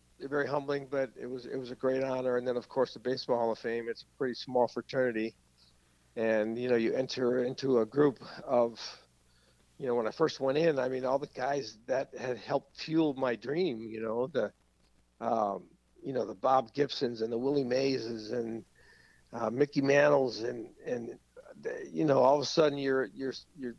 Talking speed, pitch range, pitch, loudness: 200 wpm, 115-140 Hz, 125 Hz, -32 LUFS